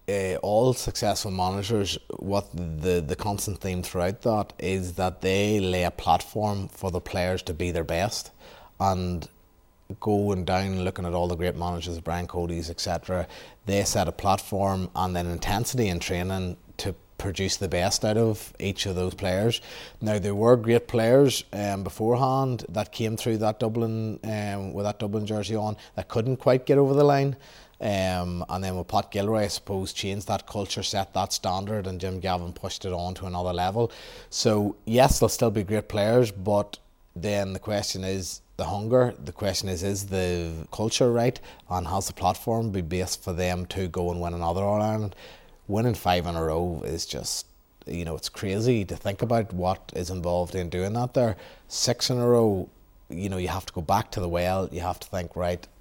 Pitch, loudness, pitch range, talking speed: 95 Hz, -27 LUFS, 90-110 Hz, 190 wpm